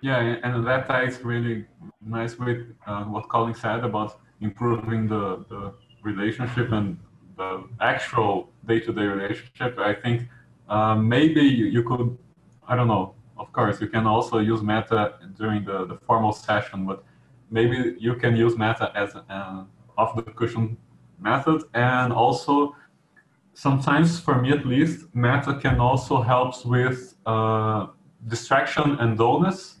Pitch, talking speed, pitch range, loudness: 115 Hz, 135 wpm, 110-125 Hz, -24 LUFS